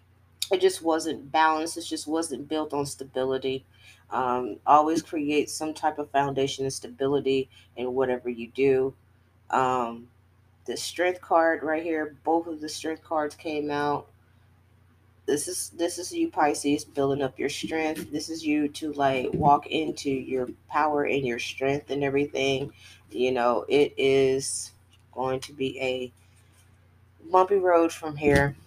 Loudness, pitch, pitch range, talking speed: -26 LUFS, 140 Hz, 120-155 Hz, 150 wpm